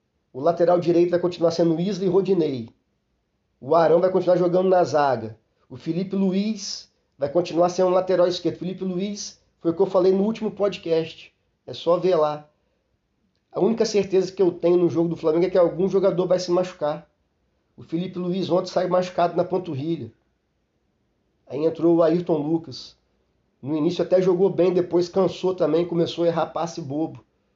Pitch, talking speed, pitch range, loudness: 175 Hz, 180 wpm, 160-185 Hz, -22 LUFS